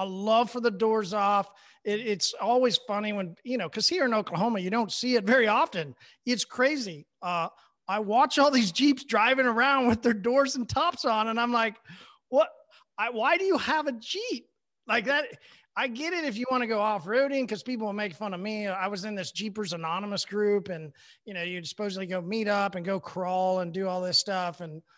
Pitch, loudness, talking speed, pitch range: 215 Hz, -27 LUFS, 225 wpm, 190-250 Hz